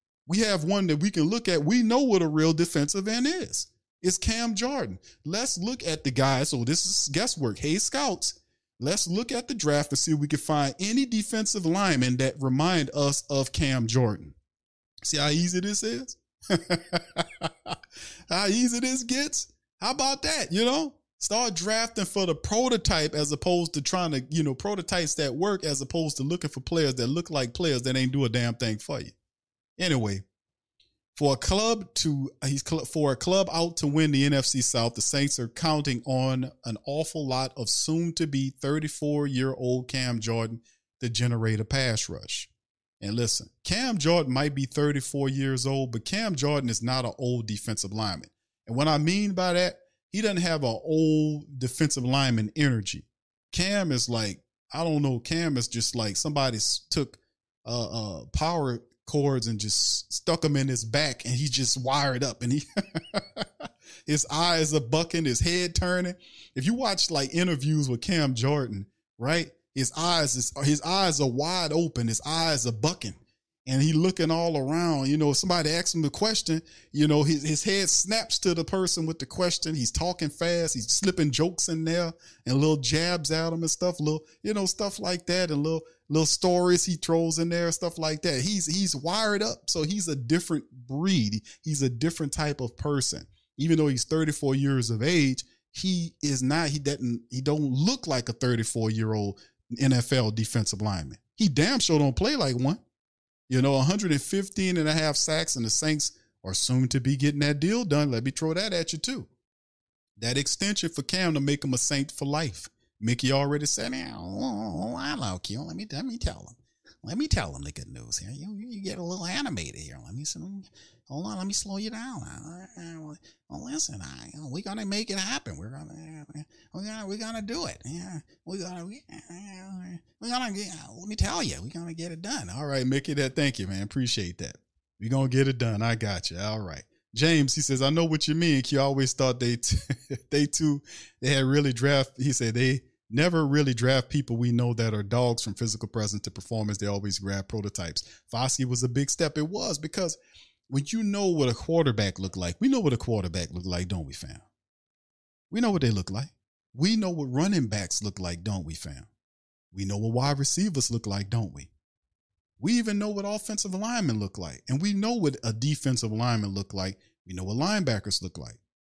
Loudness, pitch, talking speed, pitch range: -27 LUFS, 145 Hz, 200 wpm, 120-170 Hz